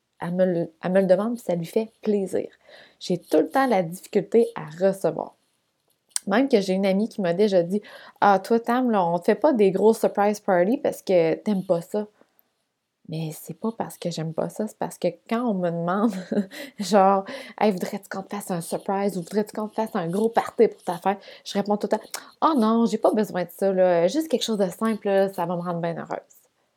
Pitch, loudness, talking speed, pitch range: 200 Hz, -24 LUFS, 230 wpm, 180-225 Hz